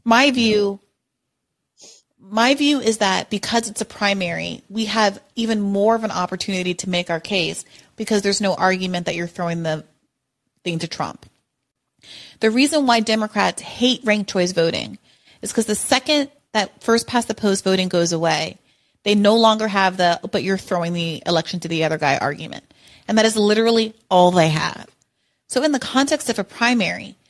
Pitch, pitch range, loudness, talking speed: 205 Hz, 180-225 Hz, -19 LUFS, 180 wpm